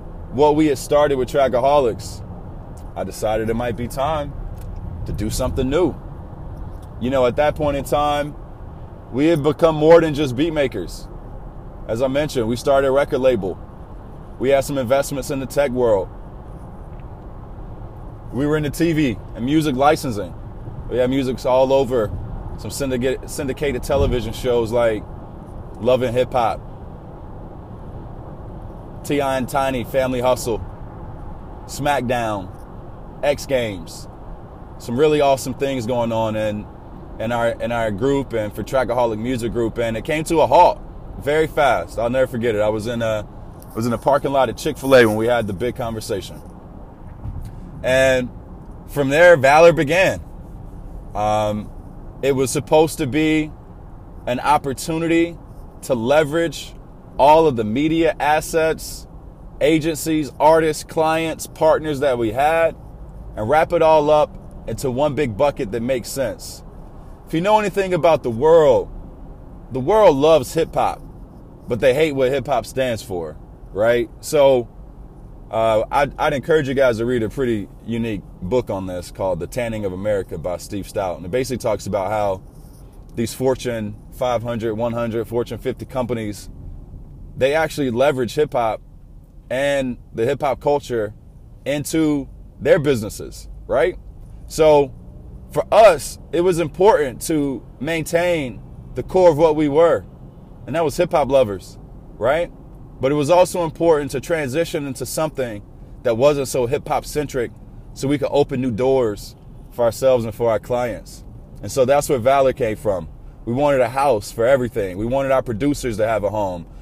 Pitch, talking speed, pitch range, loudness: 130 Hz, 155 wpm, 110-150 Hz, -19 LUFS